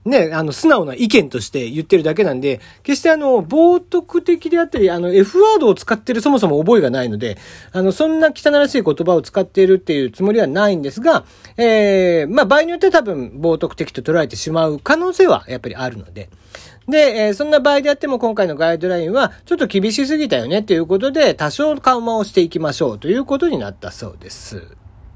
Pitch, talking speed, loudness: 200 Hz, 440 characters per minute, -15 LUFS